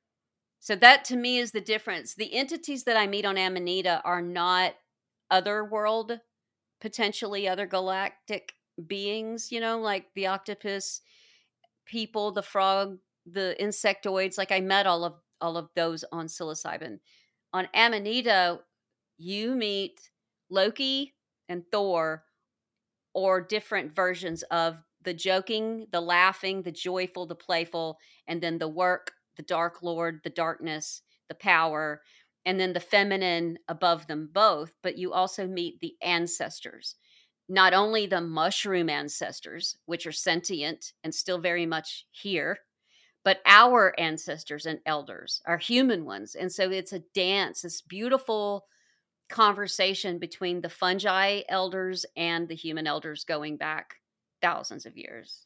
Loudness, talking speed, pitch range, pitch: -27 LUFS, 135 wpm, 170-205 Hz, 185 Hz